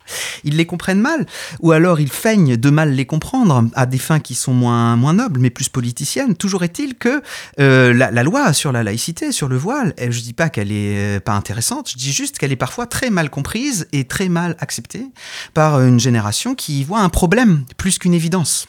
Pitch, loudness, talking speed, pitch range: 145 Hz, -16 LUFS, 215 wpm, 125-185 Hz